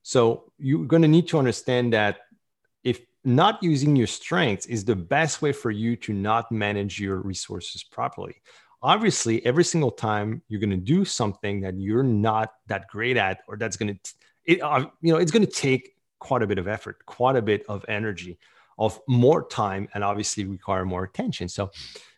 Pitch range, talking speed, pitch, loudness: 100-130 Hz, 190 wpm, 110 Hz, -24 LUFS